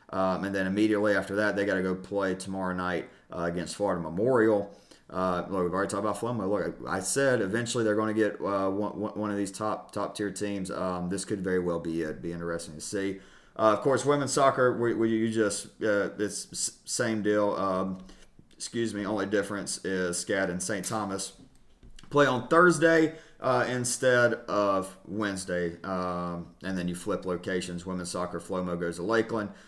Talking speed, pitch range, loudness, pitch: 190 wpm, 90-110 Hz, -29 LUFS, 100 Hz